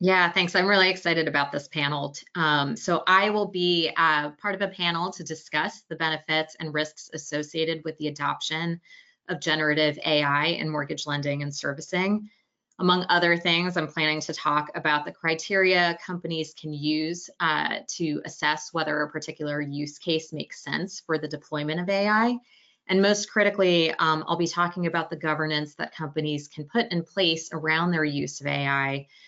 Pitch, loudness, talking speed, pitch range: 160 Hz, -25 LUFS, 175 wpm, 150-180 Hz